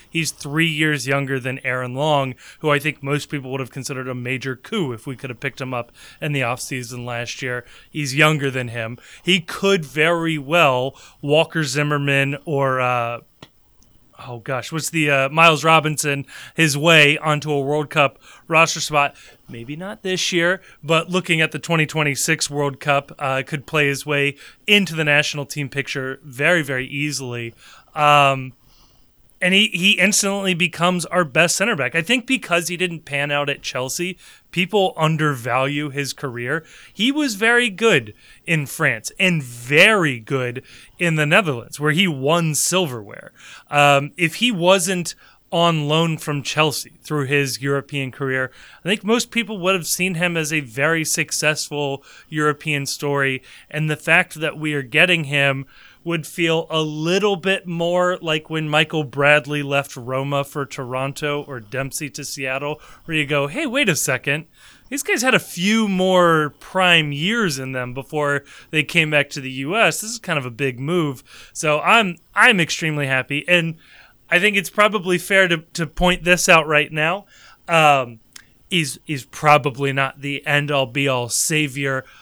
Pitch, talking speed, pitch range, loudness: 150 Hz, 170 wpm, 140-170 Hz, -19 LUFS